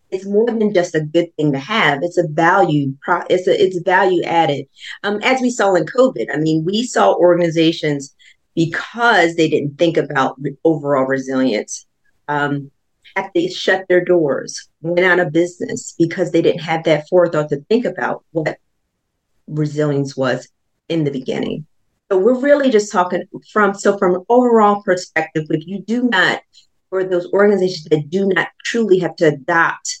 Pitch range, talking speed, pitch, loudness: 155-200 Hz, 170 wpm, 175 Hz, -16 LUFS